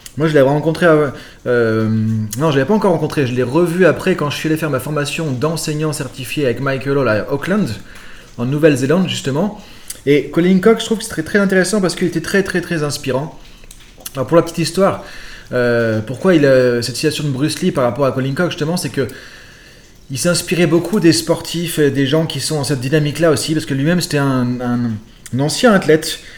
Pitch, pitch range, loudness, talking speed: 150 Hz, 135-170 Hz, -16 LUFS, 220 wpm